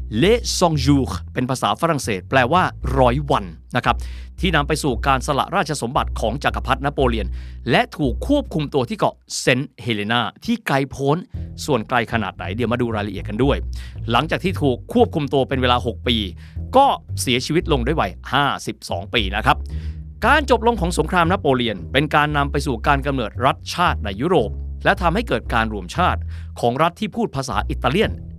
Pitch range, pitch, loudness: 90-150 Hz, 125 Hz, -20 LUFS